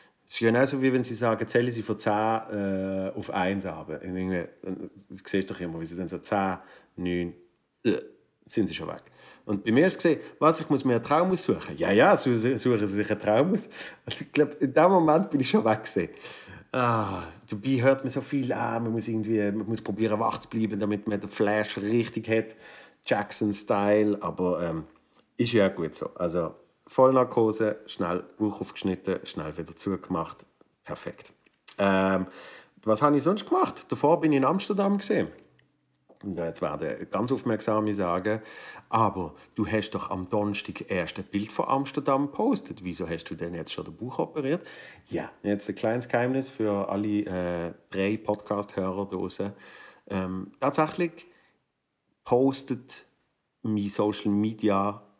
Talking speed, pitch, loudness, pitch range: 170 wpm, 105 Hz, -27 LUFS, 95-120 Hz